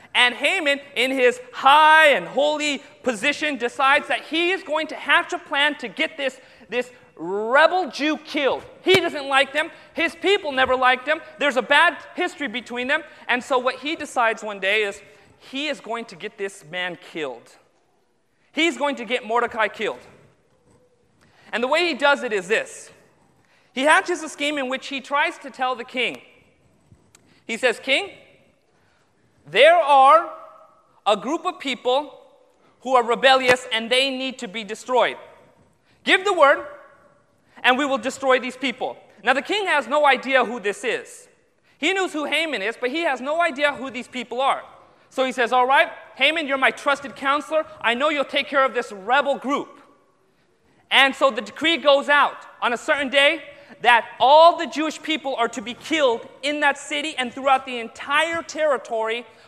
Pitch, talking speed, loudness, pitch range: 280 Hz, 180 wpm, -20 LUFS, 250-305 Hz